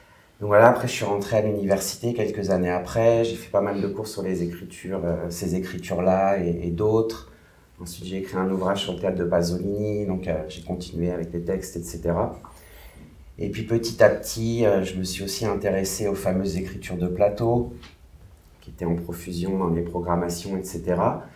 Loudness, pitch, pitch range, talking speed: -24 LUFS, 95 Hz, 85-100 Hz, 190 wpm